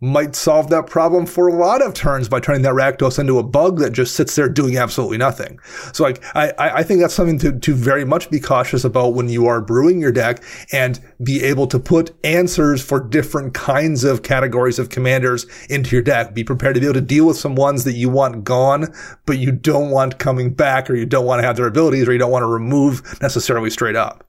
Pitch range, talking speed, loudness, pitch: 125-150 Hz, 235 wpm, -16 LUFS, 135 Hz